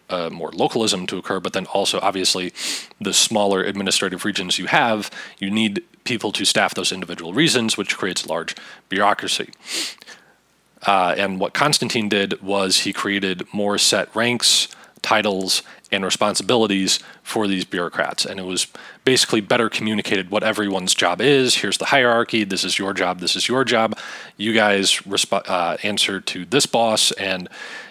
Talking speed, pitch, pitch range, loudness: 165 wpm, 100 Hz, 95-115 Hz, -19 LUFS